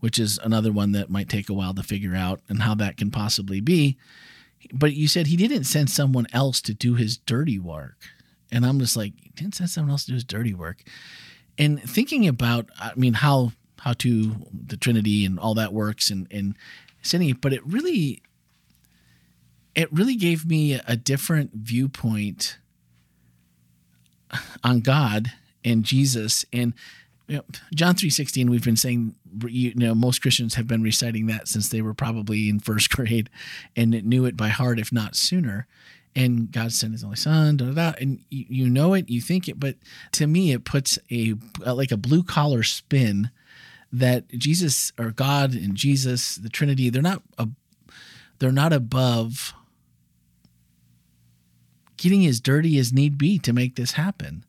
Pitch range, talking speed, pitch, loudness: 105-140 Hz, 175 wpm, 120 Hz, -23 LUFS